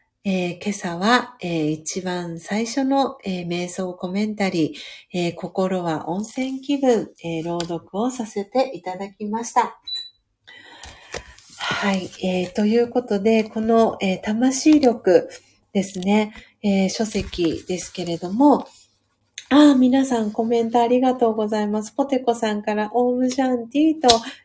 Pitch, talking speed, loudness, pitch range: 215 Hz, 230 characters per minute, -21 LUFS, 185-245 Hz